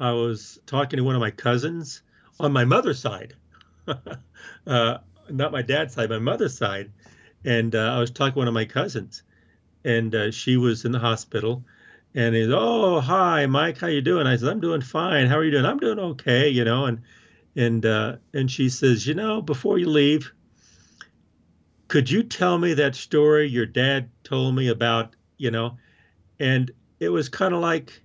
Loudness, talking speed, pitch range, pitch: -23 LUFS, 190 wpm, 115-145 Hz, 125 Hz